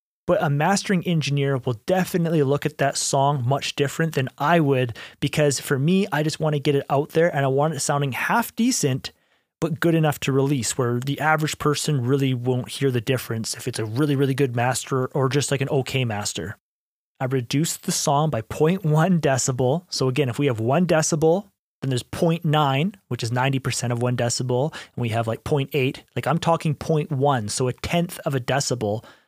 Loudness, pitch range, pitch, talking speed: -22 LUFS, 130-155 Hz, 140 Hz, 200 wpm